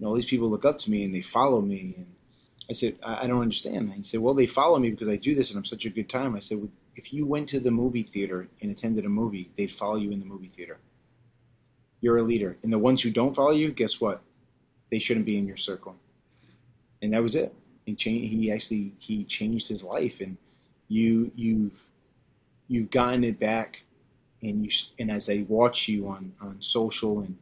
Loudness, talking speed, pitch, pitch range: -27 LUFS, 230 wpm, 115 Hz, 105-125 Hz